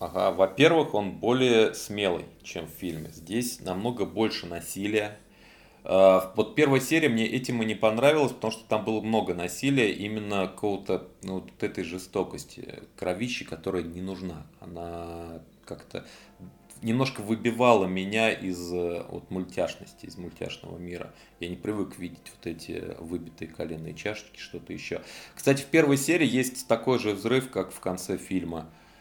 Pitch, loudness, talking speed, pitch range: 100 Hz, -27 LUFS, 145 wpm, 90-120 Hz